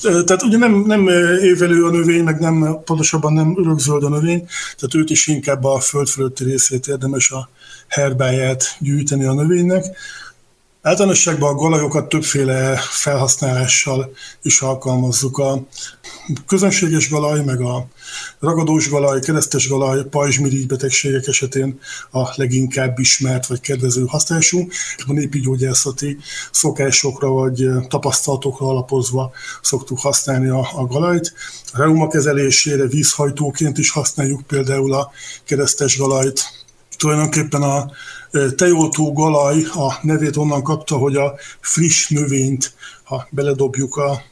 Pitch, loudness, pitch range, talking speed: 140 Hz, -16 LUFS, 135-155 Hz, 120 wpm